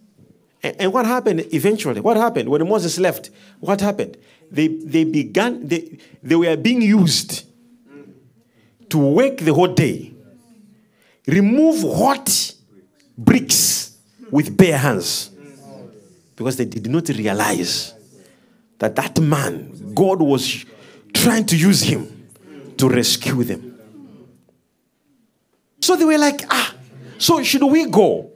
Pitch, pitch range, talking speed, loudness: 170 Hz, 145-225 Hz, 120 wpm, -17 LUFS